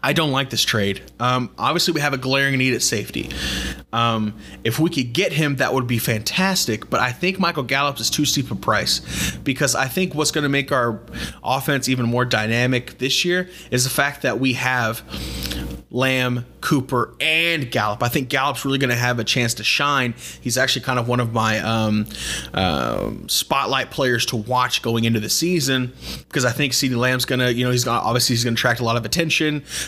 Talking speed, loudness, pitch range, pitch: 215 wpm, -20 LUFS, 115-140 Hz, 125 Hz